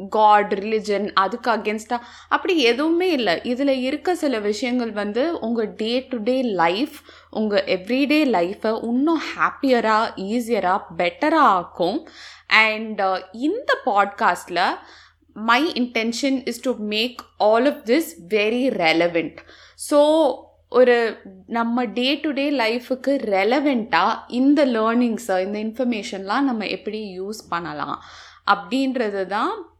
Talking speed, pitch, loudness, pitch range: 115 wpm, 235 Hz, -21 LUFS, 210-270 Hz